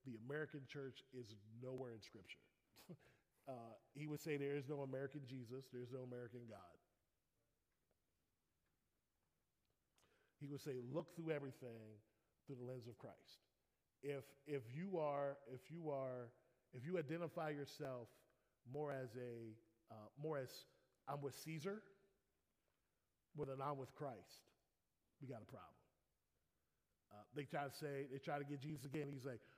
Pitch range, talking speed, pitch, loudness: 110-145 Hz, 150 wpm, 130 Hz, -51 LUFS